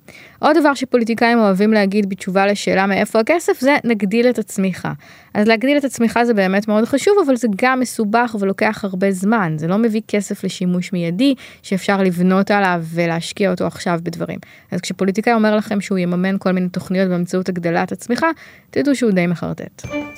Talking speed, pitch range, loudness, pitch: 170 wpm, 185-235 Hz, -17 LUFS, 205 Hz